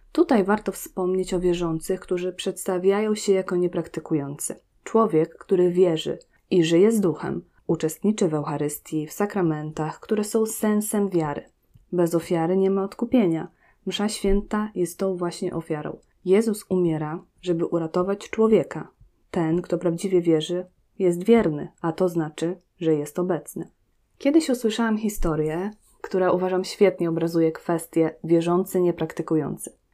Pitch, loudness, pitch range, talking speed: 180 Hz, -24 LUFS, 165-200 Hz, 130 wpm